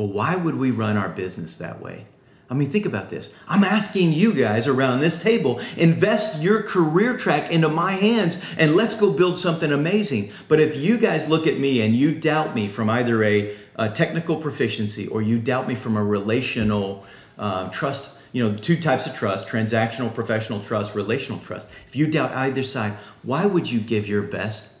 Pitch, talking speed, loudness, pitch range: 135 Hz, 200 wpm, -21 LUFS, 110-170 Hz